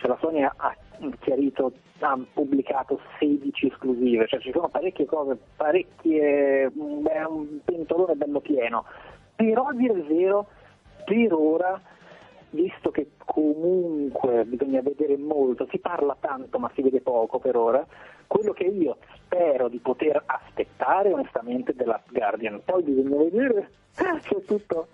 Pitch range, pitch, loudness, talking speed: 140-195 Hz, 155 Hz, -25 LUFS, 140 wpm